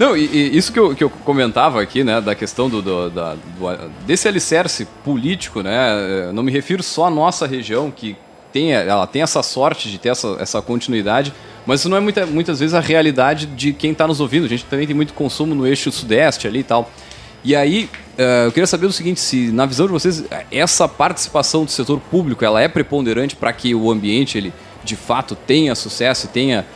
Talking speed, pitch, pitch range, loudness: 220 wpm, 135 Hz, 110-155 Hz, -17 LUFS